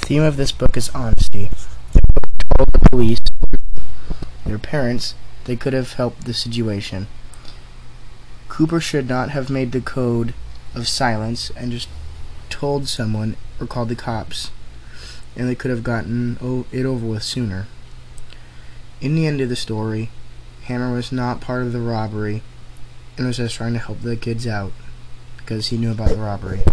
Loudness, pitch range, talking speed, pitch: -22 LUFS, 110-125 Hz, 165 wpm, 120 Hz